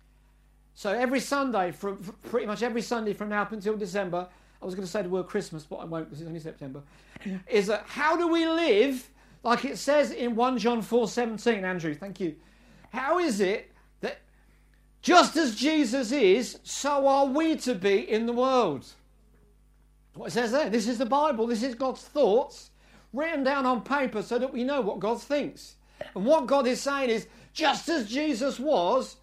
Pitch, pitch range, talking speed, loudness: 240 Hz, 205-280 Hz, 195 wpm, -27 LUFS